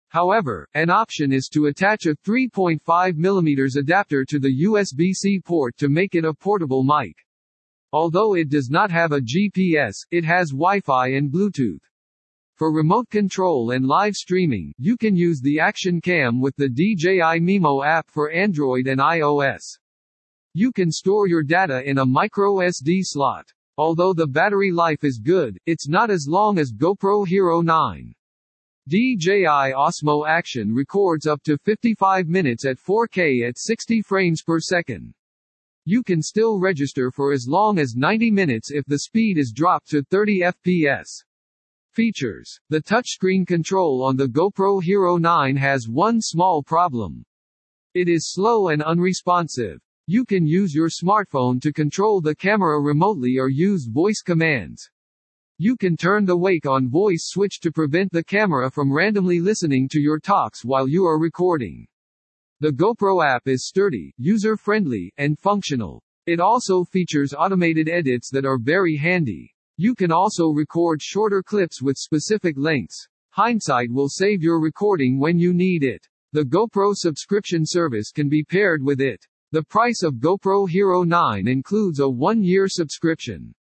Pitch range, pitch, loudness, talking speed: 140-190 Hz, 165 Hz, -20 LUFS, 155 wpm